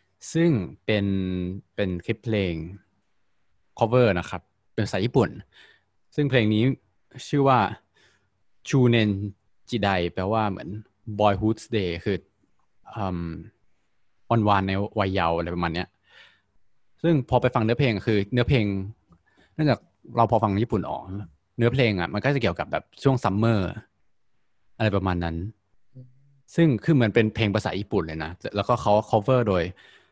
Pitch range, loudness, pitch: 95-115 Hz, -24 LUFS, 105 Hz